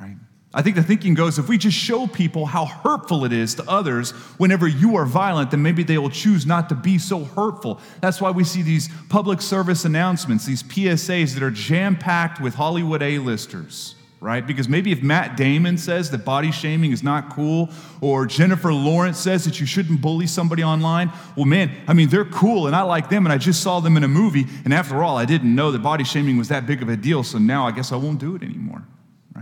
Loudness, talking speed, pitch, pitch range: -19 LUFS, 230 wpm, 160 Hz, 145-180 Hz